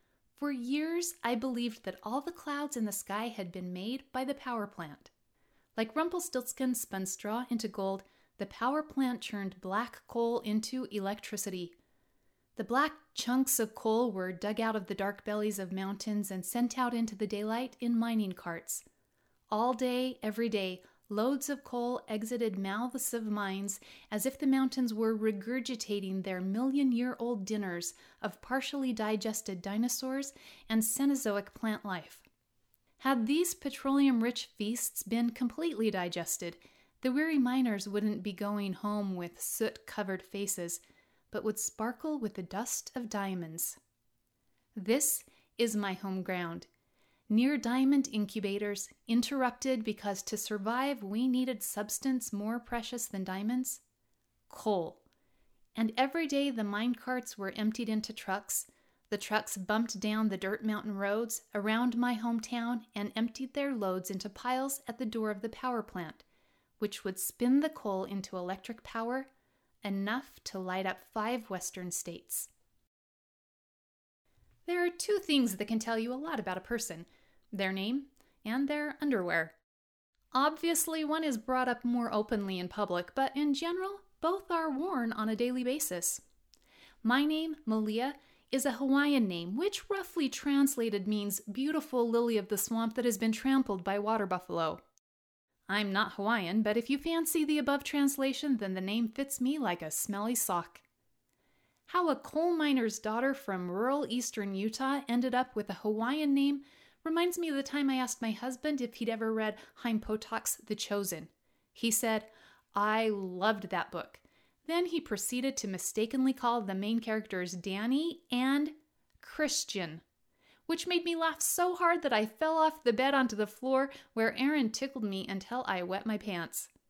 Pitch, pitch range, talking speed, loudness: 230 Hz, 205-265 Hz, 160 wpm, -34 LUFS